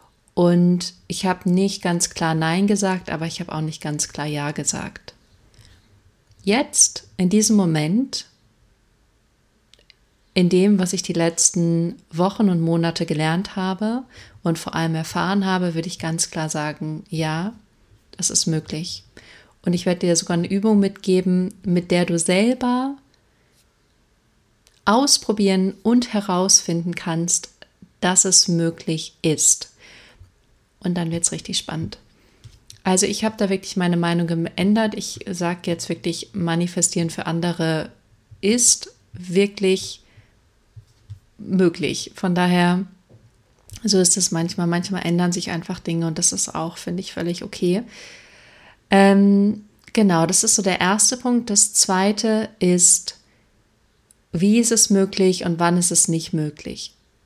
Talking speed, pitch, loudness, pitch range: 135 wpm, 175 Hz, -19 LUFS, 160-195 Hz